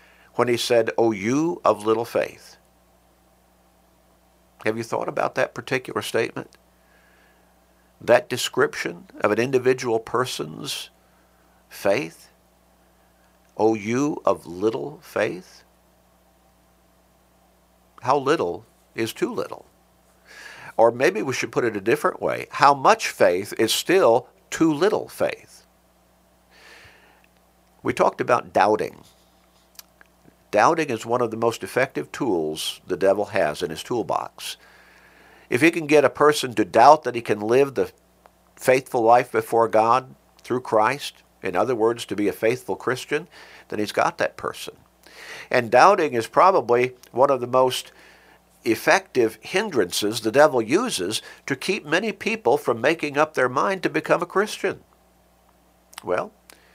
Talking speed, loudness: 135 wpm, -22 LUFS